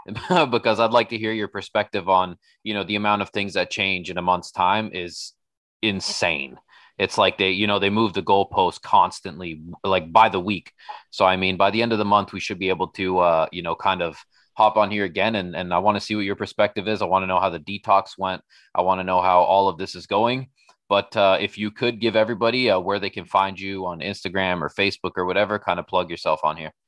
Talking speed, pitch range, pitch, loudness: 250 wpm, 95-105 Hz, 100 Hz, -22 LUFS